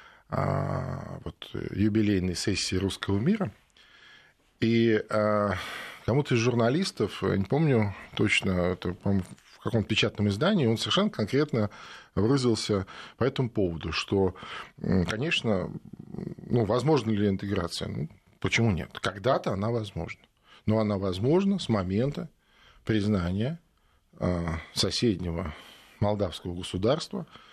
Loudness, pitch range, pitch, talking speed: -28 LUFS, 95-115 Hz, 105 Hz, 105 wpm